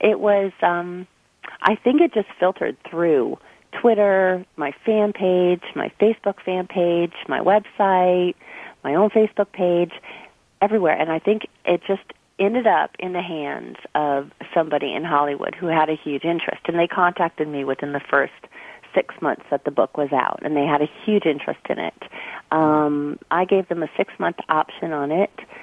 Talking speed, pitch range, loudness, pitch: 175 wpm, 155-200 Hz, -21 LUFS, 175 Hz